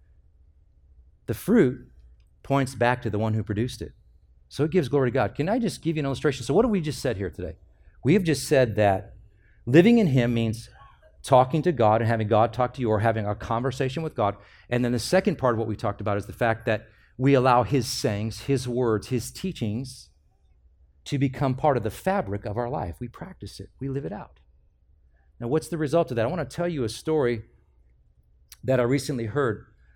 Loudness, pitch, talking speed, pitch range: -25 LUFS, 115 Hz, 220 wpm, 100-140 Hz